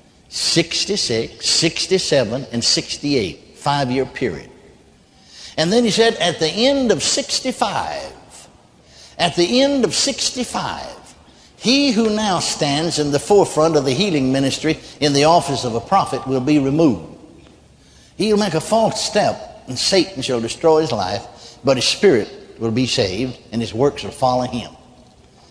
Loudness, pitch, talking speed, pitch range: -18 LUFS, 150 Hz, 150 wpm, 130-200 Hz